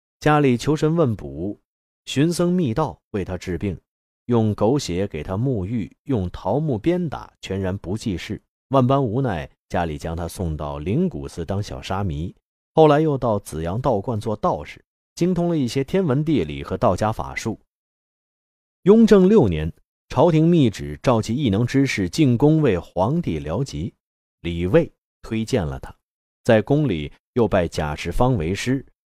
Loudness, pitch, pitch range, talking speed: -21 LUFS, 110 Hz, 85-140 Hz, 225 characters per minute